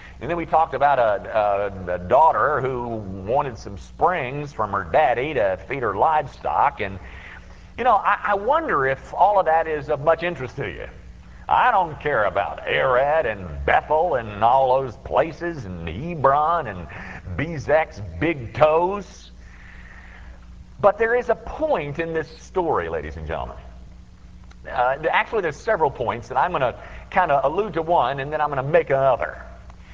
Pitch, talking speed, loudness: 120 Hz, 170 wpm, -21 LUFS